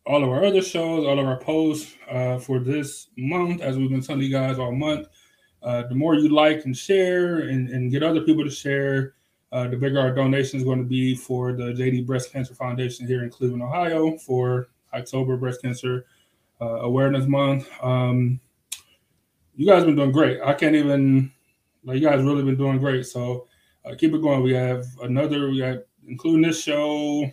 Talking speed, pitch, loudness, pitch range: 200 wpm, 135 Hz, -22 LUFS, 125-150 Hz